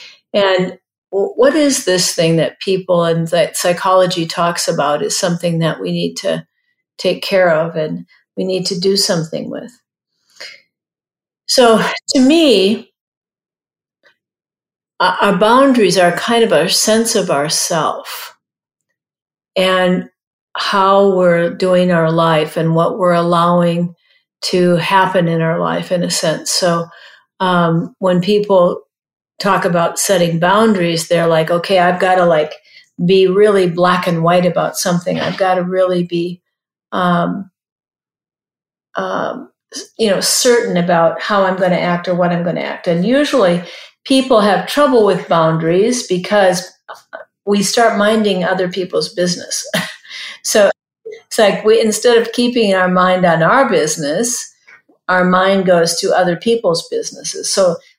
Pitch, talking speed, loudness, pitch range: 185 Hz, 140 wpm, -14 LUFS, 175-210 Hz